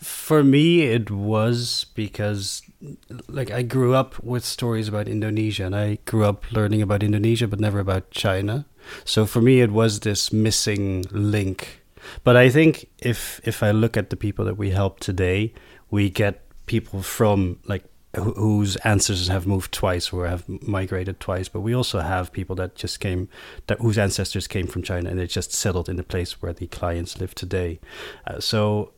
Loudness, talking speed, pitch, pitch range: -22 LUFS, 185 wpm, 105 Hz, 95-115 Hz